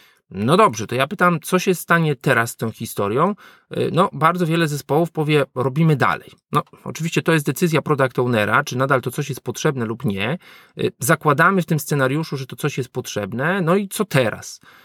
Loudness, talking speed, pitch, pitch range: -19 LUFS, 190 wpm, 150 Hz, 130-165 Hz